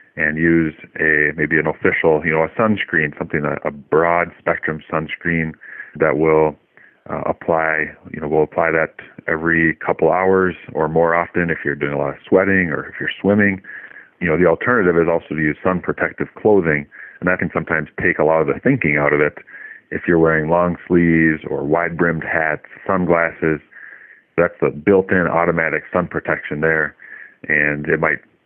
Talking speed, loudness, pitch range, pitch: 180 wpm, -17 LUFS, 75-85 Hz, 80 Hz